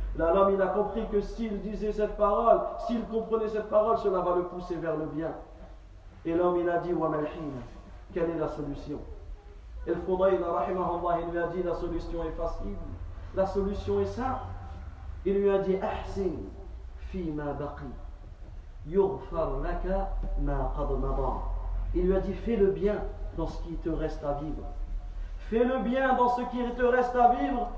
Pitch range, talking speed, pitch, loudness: 130-200 Hz, 155 wpm, 170 Hz, -29 LUFS